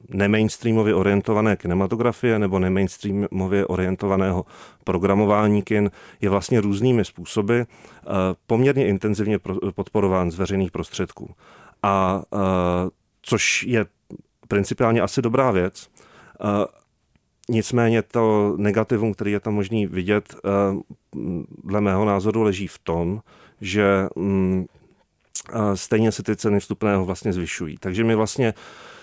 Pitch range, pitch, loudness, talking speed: 95-110 Hz, 100 Hz, -22 LUFS, 105 wpm